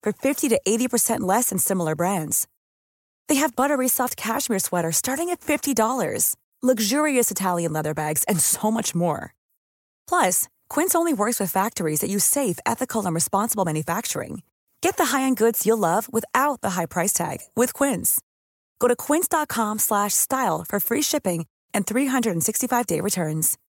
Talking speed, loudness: 155 wpm, -22 LUFS